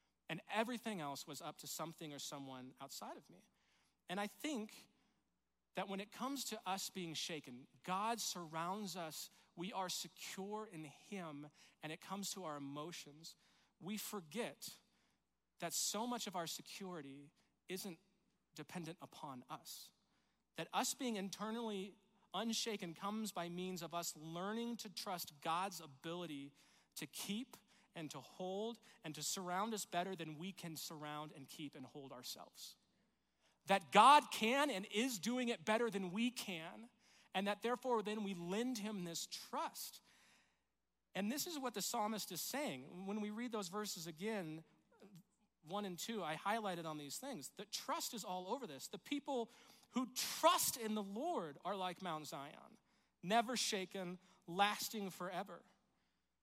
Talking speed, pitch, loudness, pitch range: 155 wpm, 190 Hz, -43 LUFS, 165-220 Hz